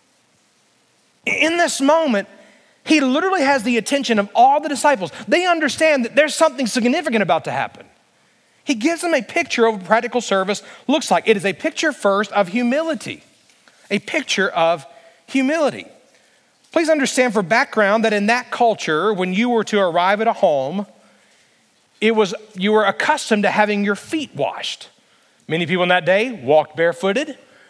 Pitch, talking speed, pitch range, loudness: 230 Hz, 165 wpm, 200-290 Hz, -18 LUFS